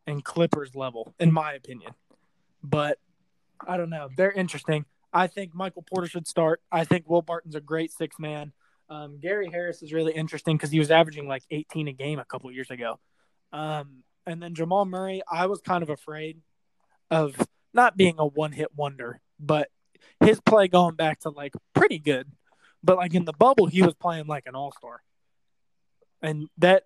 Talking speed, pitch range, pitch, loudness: 190 wpm, 150-175 Hz, 160 Hz, -25 LUFS